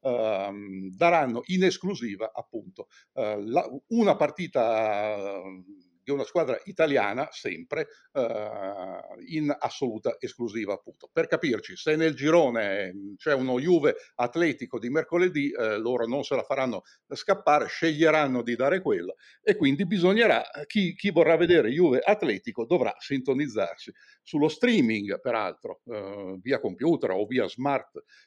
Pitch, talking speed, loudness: 160 Hz, 130 wpm, -26 LUFS